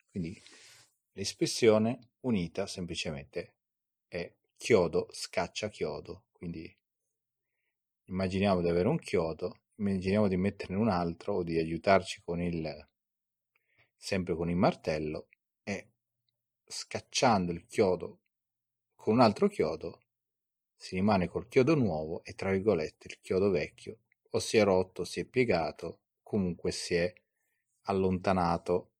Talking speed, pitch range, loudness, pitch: 120 wpm, 85-105 Hz, -31 LUFS, 95 Hz